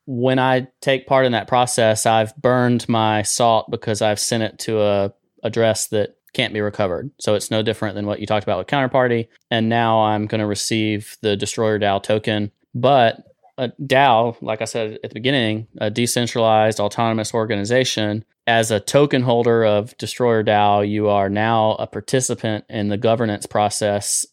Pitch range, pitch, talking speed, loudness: 105-120 Hz, 110 Hz, 180 wpm, -19 LUFS